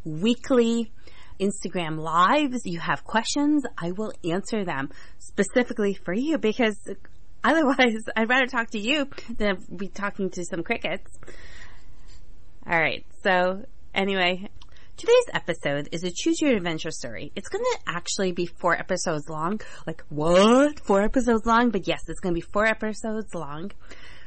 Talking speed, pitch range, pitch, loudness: 140 wpm, 175-235 Hz, 205 Hz, -25 LUFS